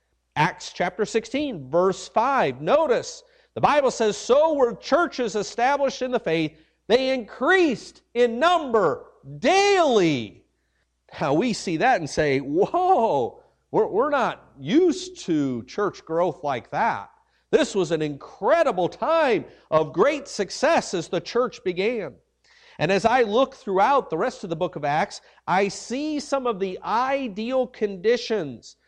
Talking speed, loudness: 140 wpm, -23 LUFS